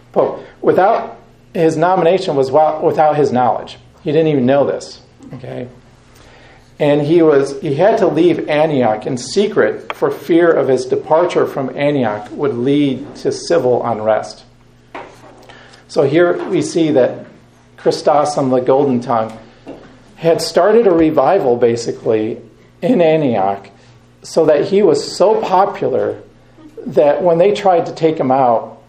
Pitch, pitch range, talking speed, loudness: 145 Hz, 125-170 Hz, 140 wpm, -14 LUFS